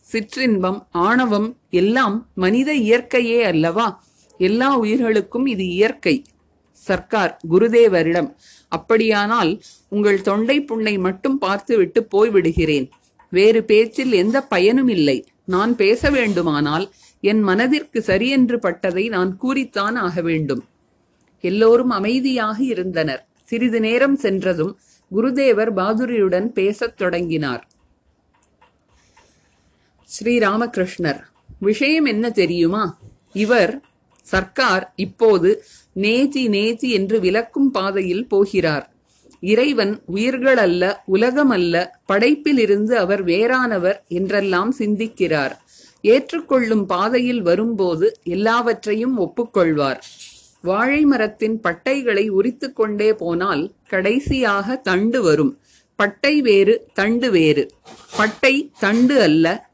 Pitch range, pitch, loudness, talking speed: 185-245 Hz, 215 Hz, -18 LUFS, 90 wpm